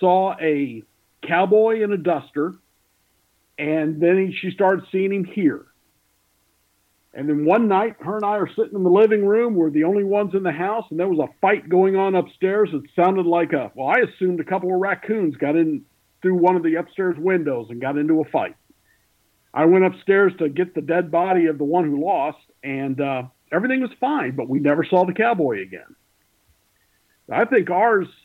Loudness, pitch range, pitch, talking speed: -20 LUFS, 155-195 Hz, 180 Hz, 200 wpm